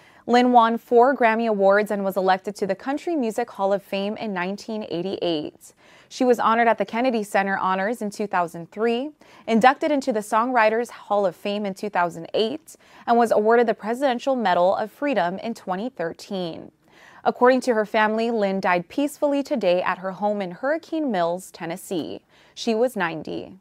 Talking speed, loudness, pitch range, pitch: 165 wpm, -22 LUFS, 195-245 Hz, 215 Hz